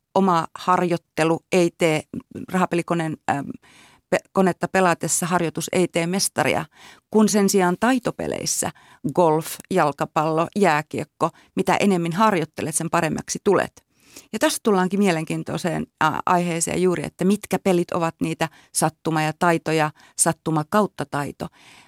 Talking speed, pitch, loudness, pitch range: 120 wpm, 175 Hz, -22 LUFS, 160-190 Hz